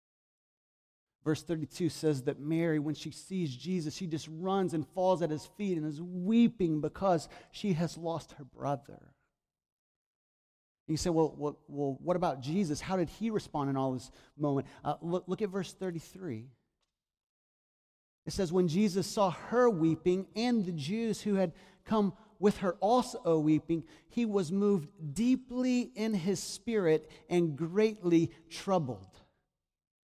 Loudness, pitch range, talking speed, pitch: -32 LUFS, 155-195 Hz, 150 wpm, 170 Hz